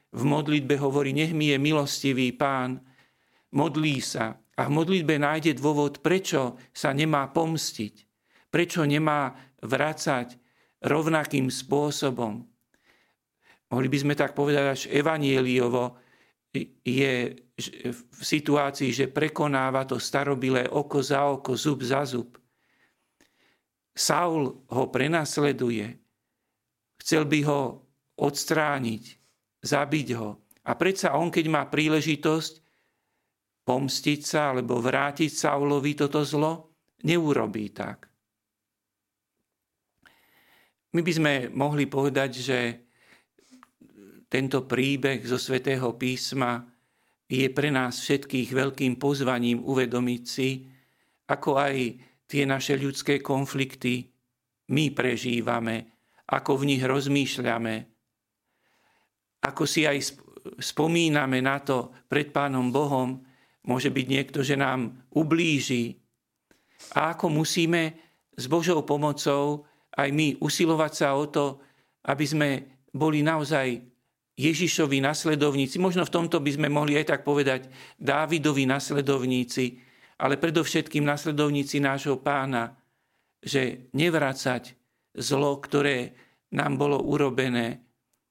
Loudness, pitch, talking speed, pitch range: -26 LUFS, 140 Hz, 105 wpm, 125-150 Hz